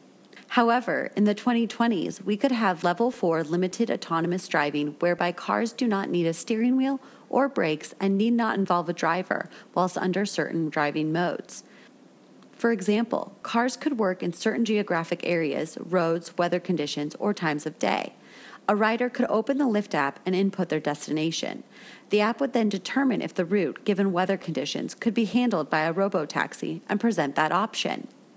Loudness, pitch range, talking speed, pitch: -26 LUFS, 170-235 Hz, 175 wpm, 195 Hz